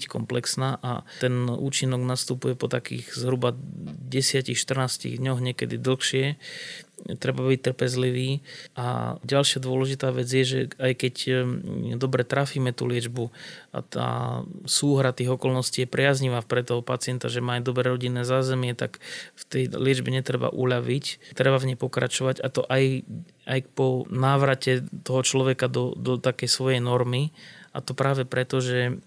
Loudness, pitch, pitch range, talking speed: -25 LUFS, 130 Hz, 125-130 Hz, 145 wpm